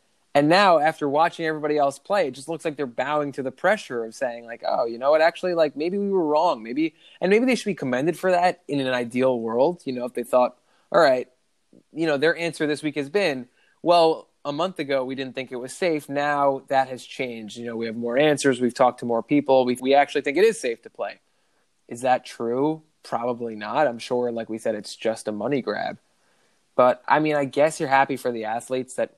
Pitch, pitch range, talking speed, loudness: 140 Hz, 125-160 Hz, 240 wpm, -23 LUFS